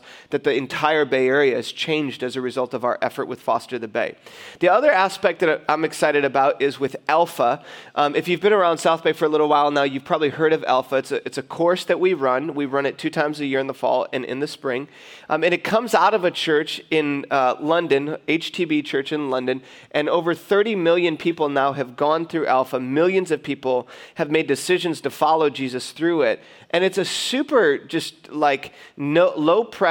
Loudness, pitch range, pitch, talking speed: -21 LUFS, 140-175 Hz, 155 Hz, 225 wpm